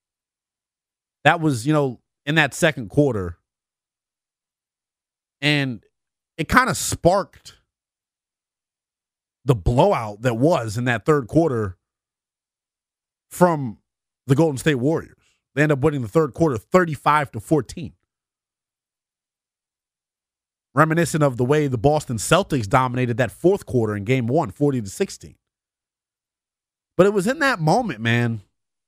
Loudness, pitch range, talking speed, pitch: -20 LUFS, 115-155 Hz, 125 wpm, 135 Hz